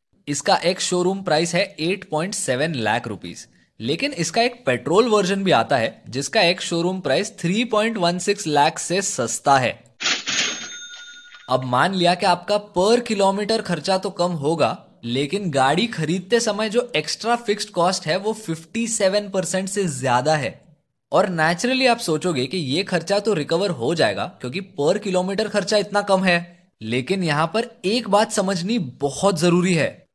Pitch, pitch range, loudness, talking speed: 185 Hz, 160-210 Hz, -21 LUFS, 155 wpm